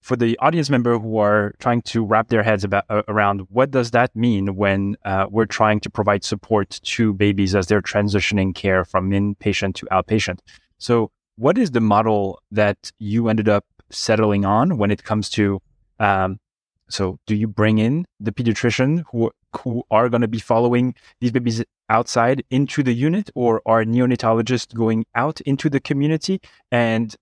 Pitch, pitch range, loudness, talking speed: 110 Hz, 100-120 Hz, -19 LUFS, 175 wpm